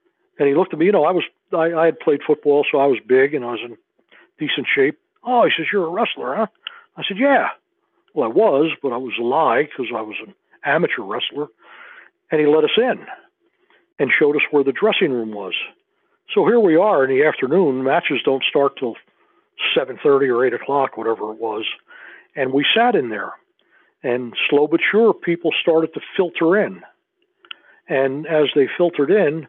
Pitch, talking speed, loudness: 190 Hz, 200 wpm, -18 LUFS